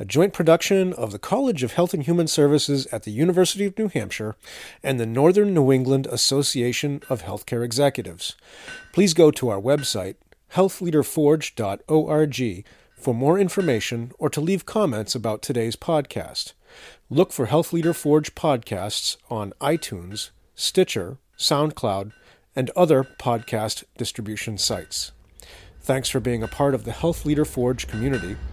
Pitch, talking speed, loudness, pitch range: 140 Hz, 145 wpm, -22 LUFS, 115-165 Hz